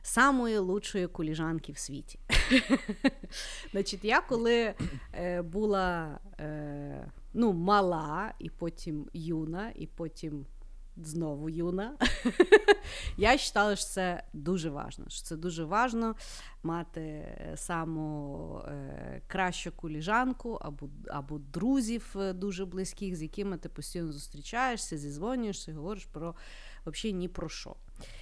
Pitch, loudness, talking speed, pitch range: 180 Hz, -32 LUFS, 100 wpm, 155-210 Hz